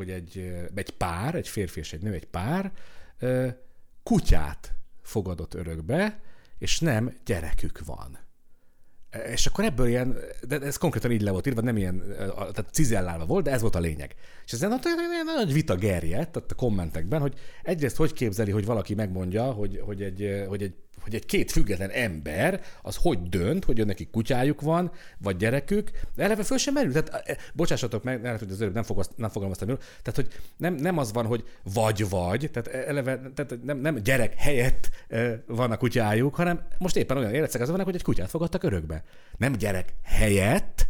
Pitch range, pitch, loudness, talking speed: 100-145 Hz, 115 Hz, -28 LUFS, 175 wpm